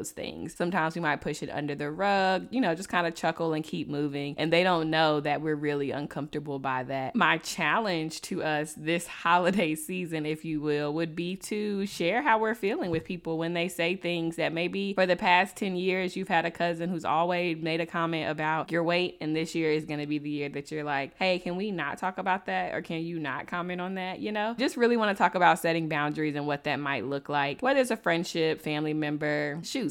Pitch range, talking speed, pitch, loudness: 150-180 Hz, 240 wpm, 165 Hz, -29 LUFS